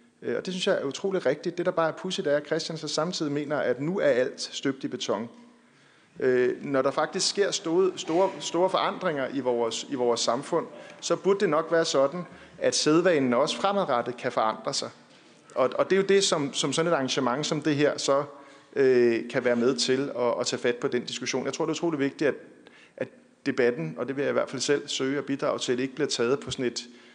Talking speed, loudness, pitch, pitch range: 235 wpm, -26 LUFS, 145 Hz, 130-180 Hz